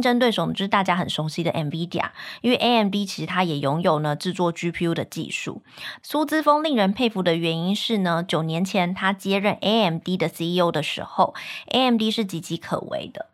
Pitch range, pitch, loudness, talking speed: 170-225 Hz, 185 Hz, -23 LUFS, 340 characters per minute